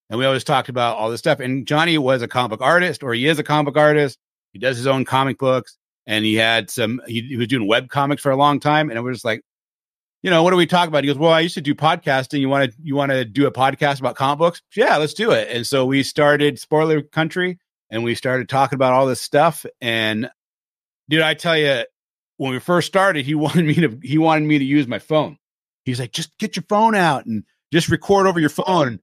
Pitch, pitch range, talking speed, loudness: 145 Hz, 130-160 Hz, 260 wpm, -18 LUFS